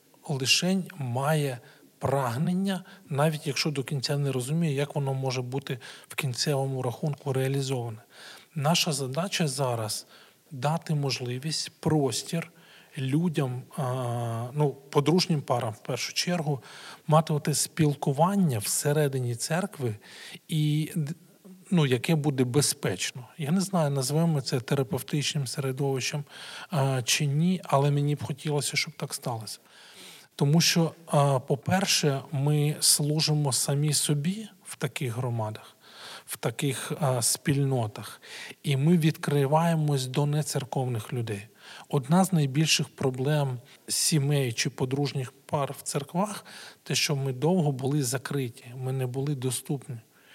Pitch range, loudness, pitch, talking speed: 135-160 Hz, -27 LUFS, 145 Hz, 115 wpm